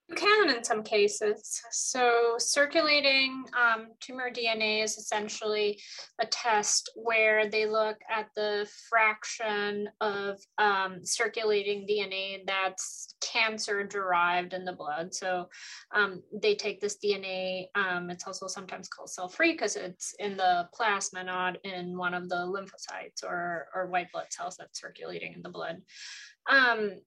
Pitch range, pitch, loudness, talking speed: 190-225 Hz, 210 Hz, -29 LUFS, 145 wpm